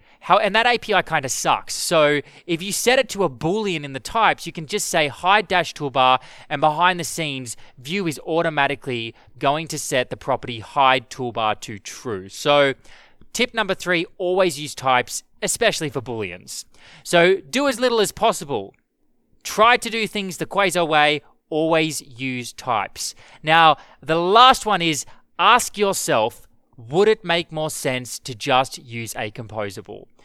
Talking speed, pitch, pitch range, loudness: 165 wpm, 155 Hz, 130-185 Hz, -20 LUFS